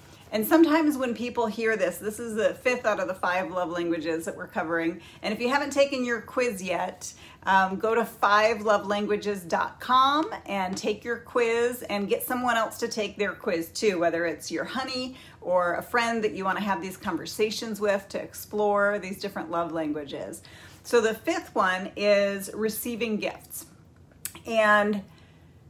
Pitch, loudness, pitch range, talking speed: 210 Hz, -26 LUFS, 185-235 Hz, 170 wpm